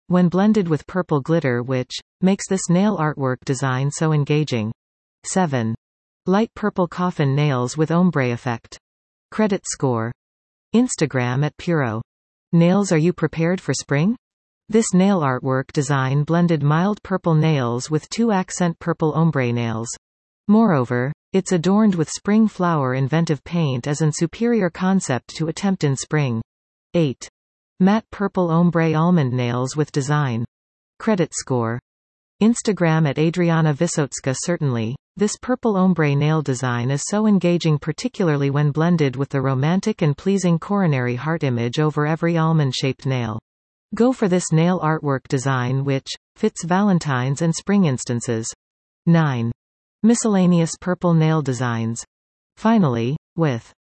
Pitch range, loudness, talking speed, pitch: 130-180 Hz, -20 LUFS, 135 wpm, 155 Hz